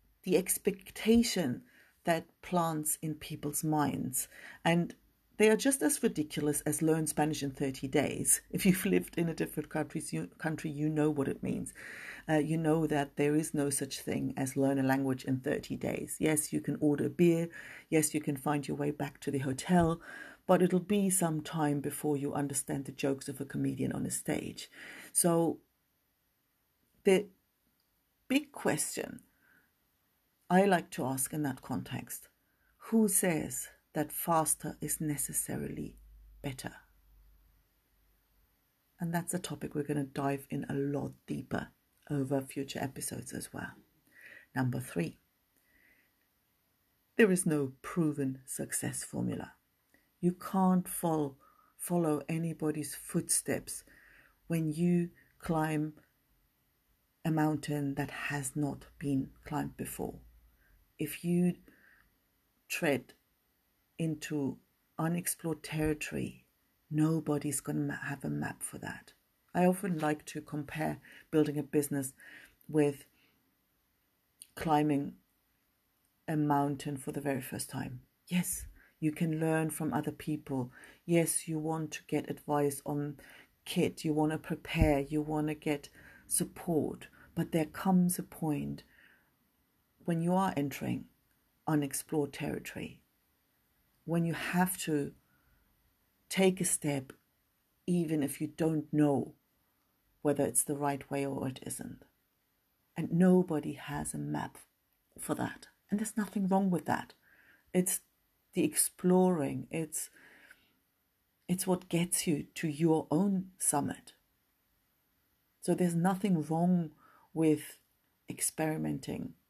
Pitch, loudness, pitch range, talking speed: 150 Hz, -33 LUFS, 140-165 Hz, 130 wpm